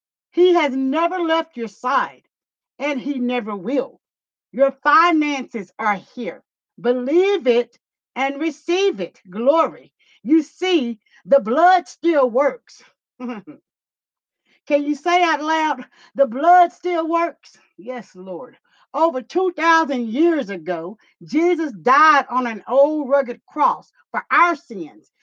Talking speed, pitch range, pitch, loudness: 120 wpm, 245-325 Hz, 280 Hz, -19 LUFS